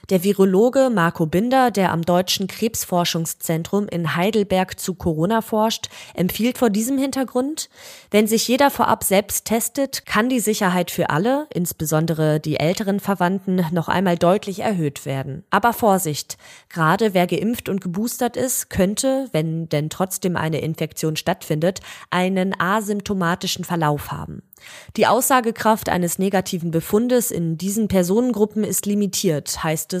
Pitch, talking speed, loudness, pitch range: 190 Hz, 135 wpm, -20 LUFS, 170-220 Hz